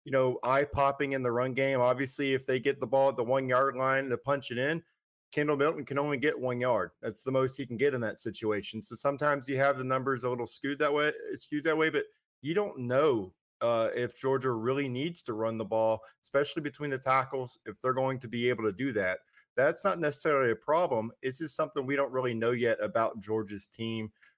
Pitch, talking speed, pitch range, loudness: 130 Hz, 235 wpm, 120-140 Hz, -30 LUFS